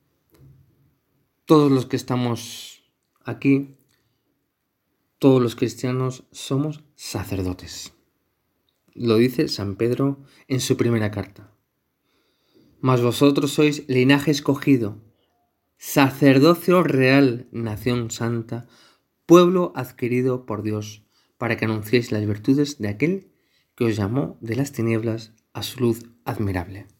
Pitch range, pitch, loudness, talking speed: 110-140 Hz, 125 Hz, -21 LUFS, 105 wpm